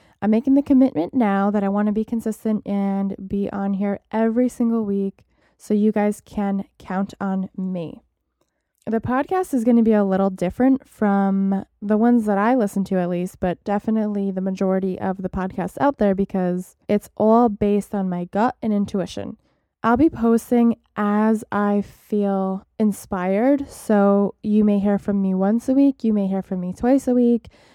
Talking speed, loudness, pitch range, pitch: 185 wpm, -21 LUFS, 195-230 Hz, 205 Hz